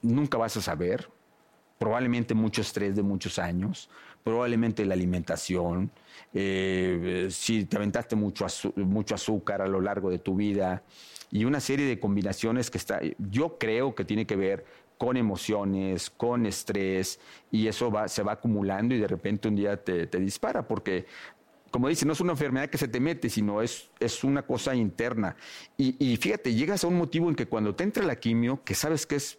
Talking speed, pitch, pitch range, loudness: 185 wpm, 110 Hz, 95-120 Hz, -29 LUFS